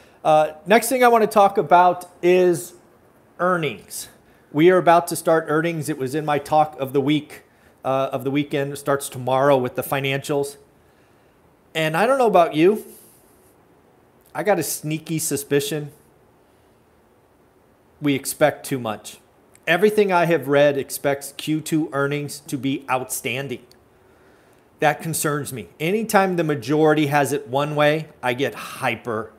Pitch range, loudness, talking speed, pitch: 140-165 Hz, -20 LUFS, 145 wpm, 150 Hz